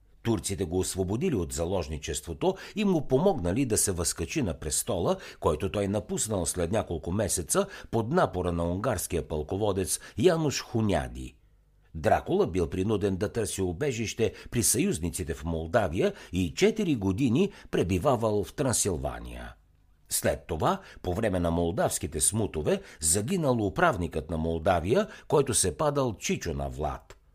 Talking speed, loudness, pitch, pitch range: 130 wpm, -28 LUFS, 95 Hz, 85-110 Hz